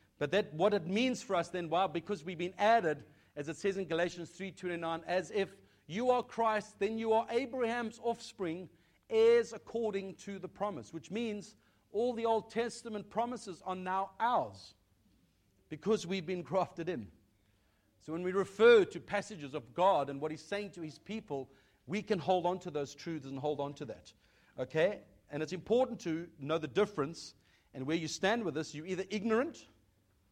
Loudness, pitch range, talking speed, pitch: -35 LUFS, 150-210 Hz, 185 wpm, 185 Hz